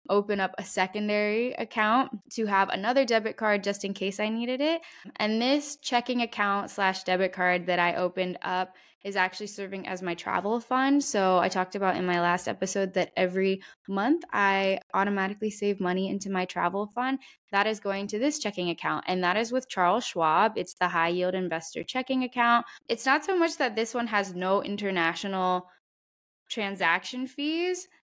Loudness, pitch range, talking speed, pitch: -27 LUFS, 185-235 Hz, 180 wpm, 200 Hz